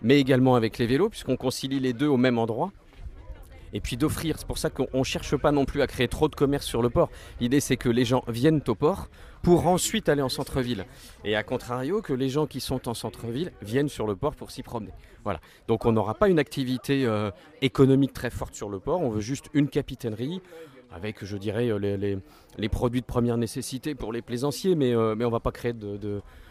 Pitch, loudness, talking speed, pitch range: 125 Hz, -26 LUFS, 235 wpm, 115-140 Hz